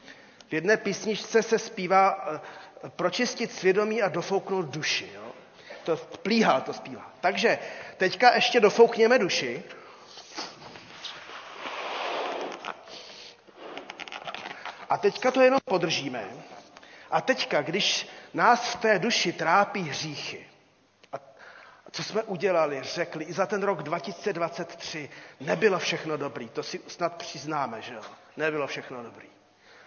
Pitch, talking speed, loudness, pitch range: 190 Hz, 115 wpm, -26 LUFS, 160-220 Hz